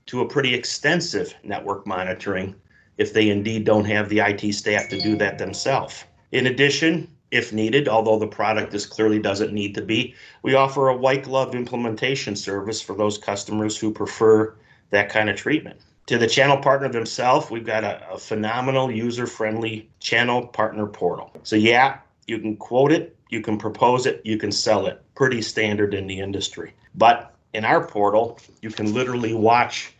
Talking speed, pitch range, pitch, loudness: 175 wpm, 105-125 Hz, 110 Hz, -21 LUFS